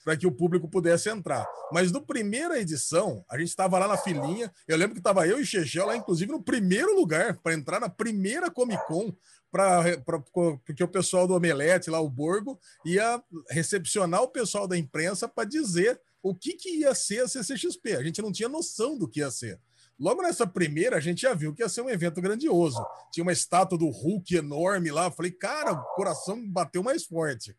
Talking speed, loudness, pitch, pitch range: 200 wpm, -27 LUFS, 180 Hz, 165-225 Hz